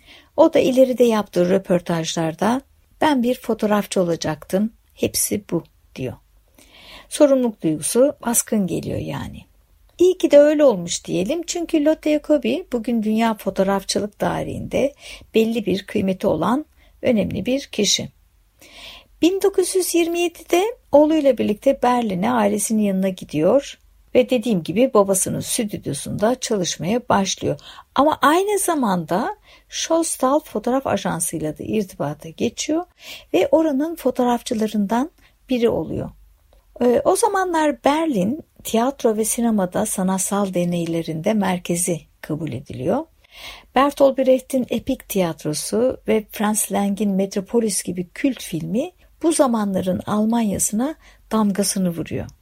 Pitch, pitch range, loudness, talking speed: 230 Hz, 195-275 Hz, -20 LUFS, 105 wpm